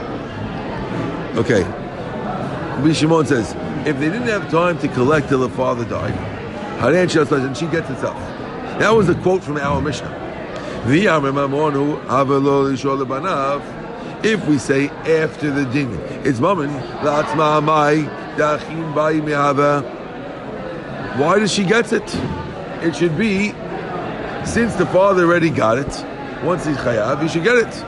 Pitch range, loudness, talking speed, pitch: 140-175 Hz, -18 LUFS, 120 wpm, 150 Hz